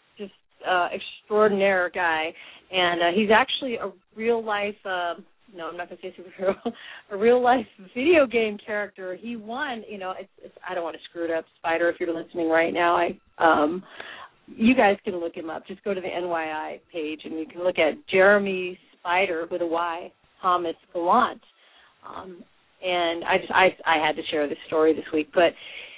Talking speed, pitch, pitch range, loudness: 195 wpm, 180 Hz, 170-205 Hz, -24 LUFS